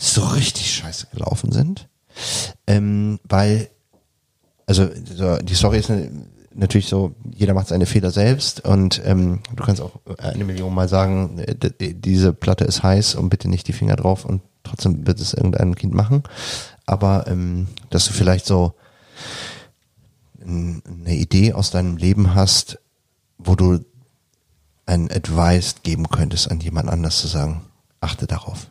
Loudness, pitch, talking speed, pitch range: -19 LUFS, 95 Hz, 145 wpm, 90-105 Hz